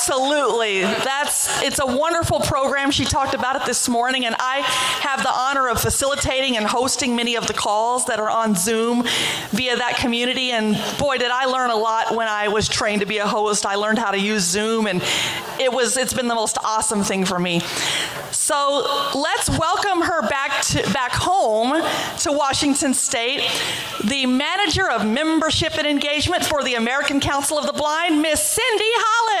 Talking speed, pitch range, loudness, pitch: 185 wpm, 225-285 Hz, -19 LUFS, 255 Hz